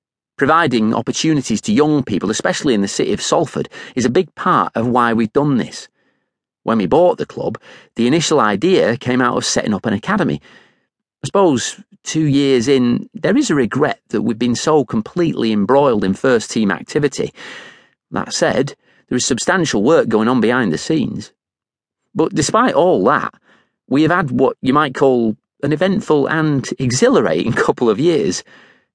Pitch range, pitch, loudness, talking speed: 120-155 Hz, 130 Hz, -16 LUFS, 170 wpm